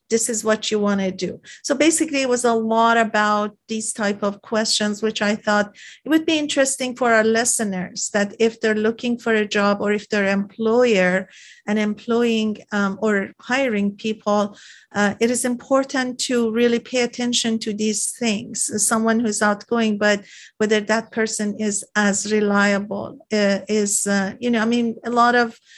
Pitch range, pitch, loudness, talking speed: 205-235 Hz, 220 Hz, -20 LUFS, 180 wpm